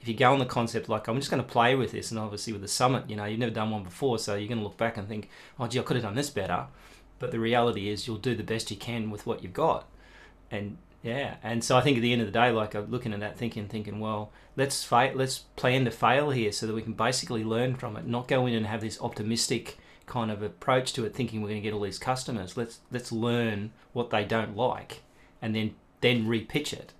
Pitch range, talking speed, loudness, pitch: 105-125 Hz, 275 wpm, -29 LUFS, 115 Hz